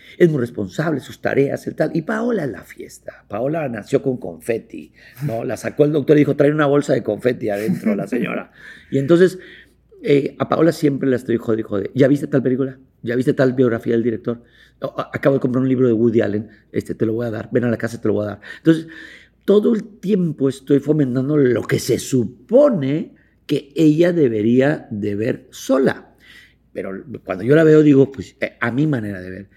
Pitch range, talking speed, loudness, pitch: 115-150 Hz, 205 wpm, -18 LUFS, 135 Hz